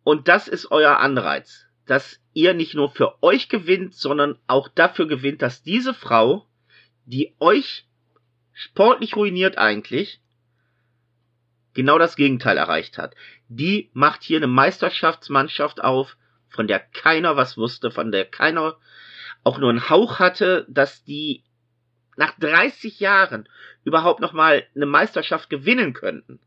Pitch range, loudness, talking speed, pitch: 120-170 Hz, -19 LUFS, 135 wpm, 140 Hz